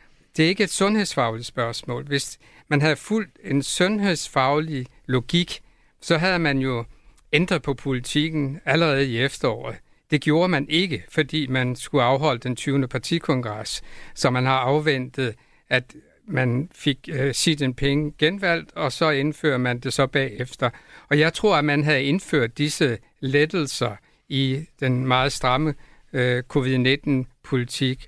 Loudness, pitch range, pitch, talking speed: -23 LUFS, 130-155 Hz, 140 Hz, 140 wpm